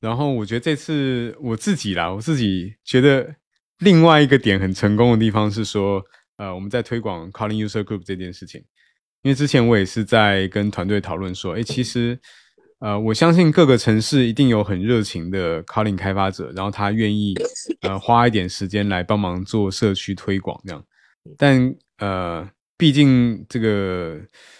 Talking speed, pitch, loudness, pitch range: 300 characters per minute, 110 Hz, -19 LUFS, 95-125 Hz